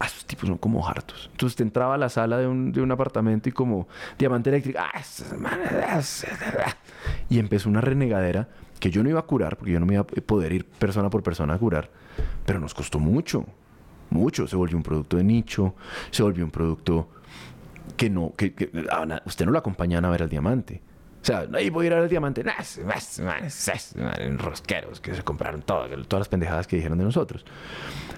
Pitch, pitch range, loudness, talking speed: 95 Hz, 85-120 Hz, -26 LUFS, 215 wpm